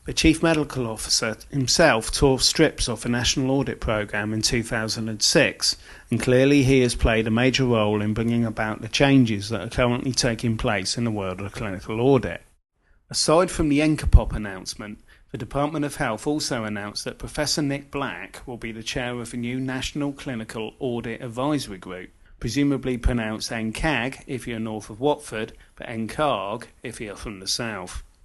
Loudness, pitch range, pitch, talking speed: -23 LUFS, 110-135 Hz, 120 Hz, 170 wpm